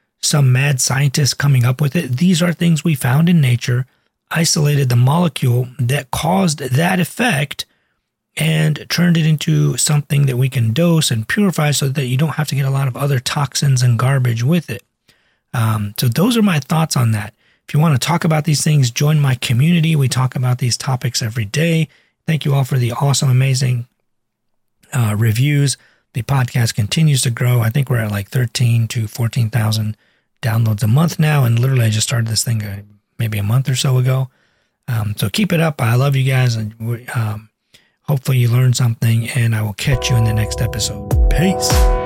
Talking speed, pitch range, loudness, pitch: 200 wpm, 120-150 Hz, -16 LUFS, 130 Hz